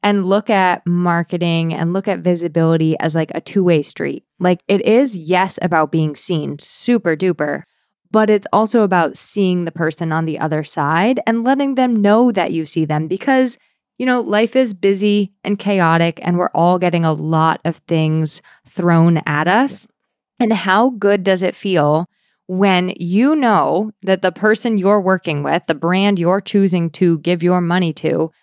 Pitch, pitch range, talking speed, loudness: 180 Hz, 165-205 Hz, 180 wpm, -16 LUFS